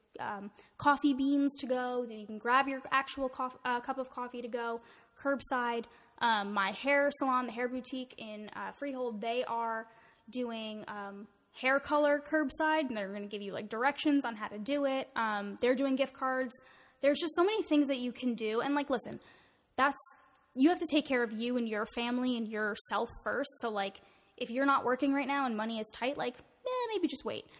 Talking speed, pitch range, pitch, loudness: 210 wpm, 230-275 Hz, 255 Hz, -33 LUFS